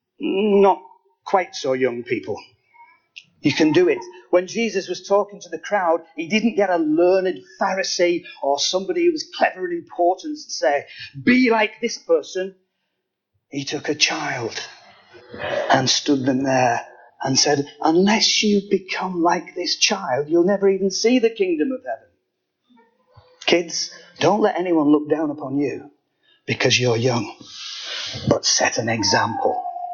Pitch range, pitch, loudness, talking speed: 160-230 Hz, 185 Hz, -20 LUFS, 150 wpm